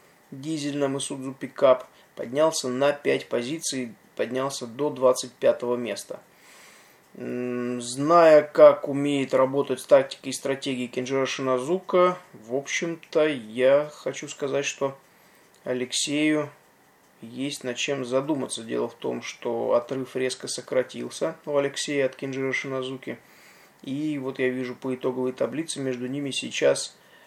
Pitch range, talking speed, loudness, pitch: 130-145 Hz, 120 wpm, -25 LUFS, 135 Hz